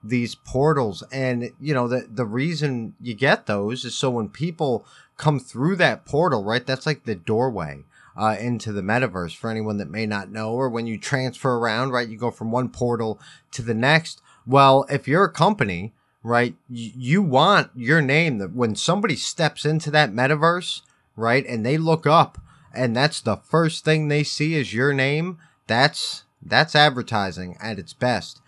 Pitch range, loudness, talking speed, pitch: 115-150 Hz, -21 LUFS, 185 wpm, 130 Hz